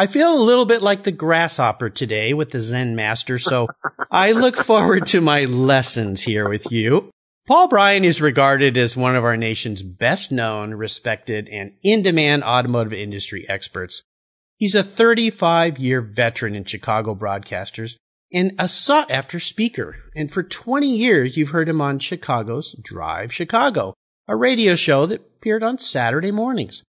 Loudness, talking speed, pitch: -18 LUFS, 160 wpm, 140 Hz